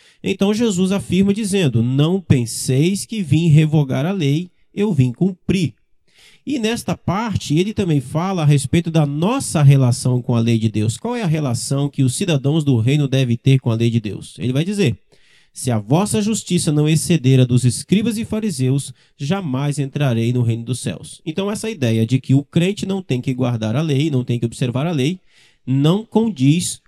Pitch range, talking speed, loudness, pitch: 130-185 Hz, 195 wpm, -18 LUFS, 145 Hz